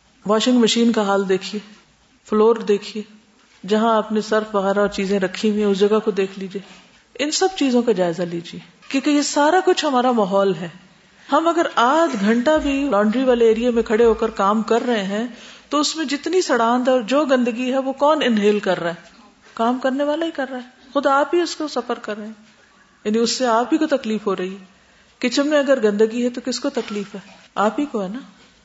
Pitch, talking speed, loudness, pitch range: 230 Hz, 220 wpm, -19 LUFS, 210-270 Hz